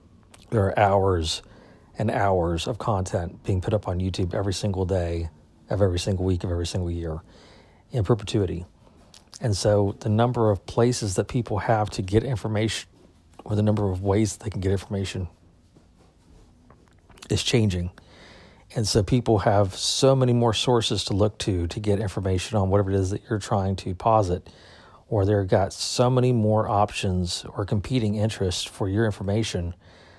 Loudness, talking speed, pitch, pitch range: -24 LUFS, 170 wpm, 100 Hz, 90-110 Hz